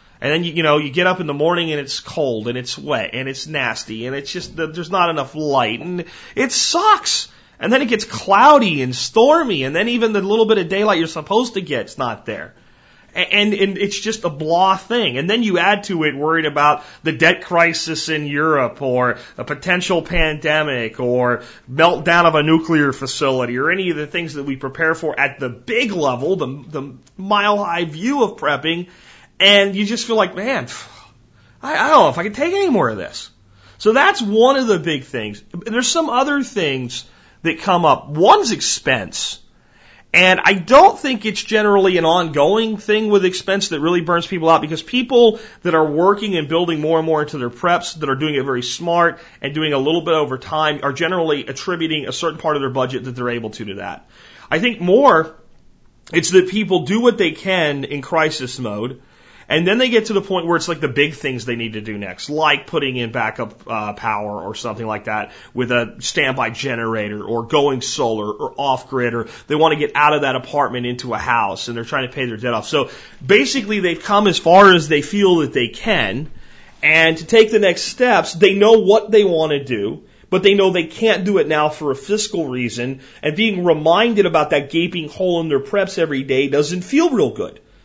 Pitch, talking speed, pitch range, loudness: 160 Hz, 215 wpm, 135-195 Hz, -16 LUFS